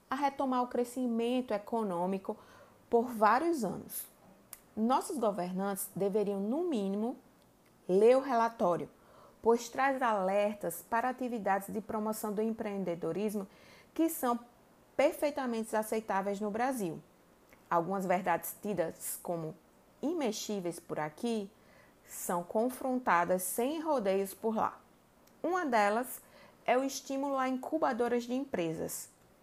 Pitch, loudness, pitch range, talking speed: 225 Hz, -33 LUFS, 200-255 Hz, 110 wpm